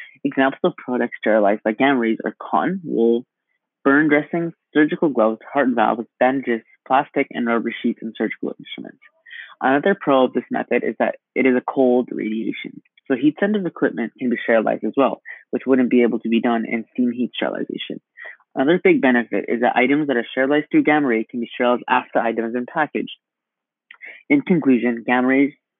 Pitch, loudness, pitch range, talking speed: 125 Hz, -19 LUFS, 115-145 Hz, 190 wpm